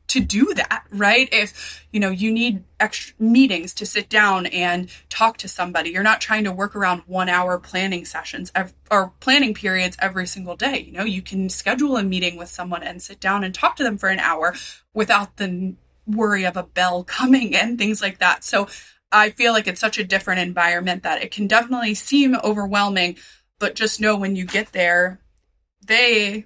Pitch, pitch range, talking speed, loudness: 200 Hz, 180-220 Hz, 200 wpm, -19 LUFS